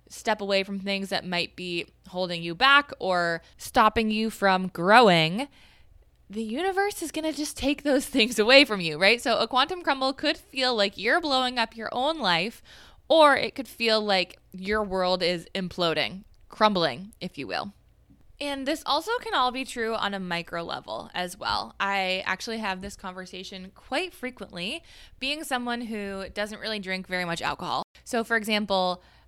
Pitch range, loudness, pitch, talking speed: 185-260 Hz, -25 LUFS, 215 Hz, 175 wpm